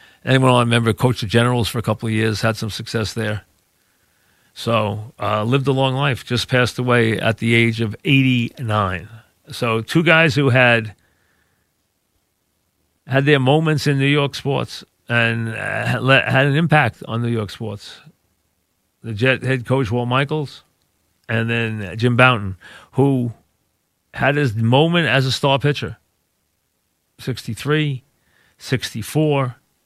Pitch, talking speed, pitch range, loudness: 120 Hz, 140 wpm, 105-135 Hz, -18 LUFS